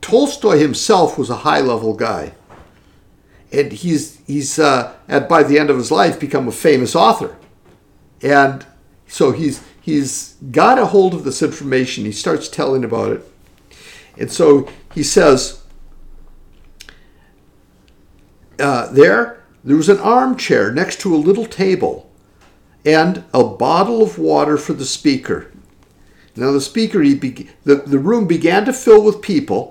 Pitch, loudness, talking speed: 140 Hz, -15 LUFS, 145 wpm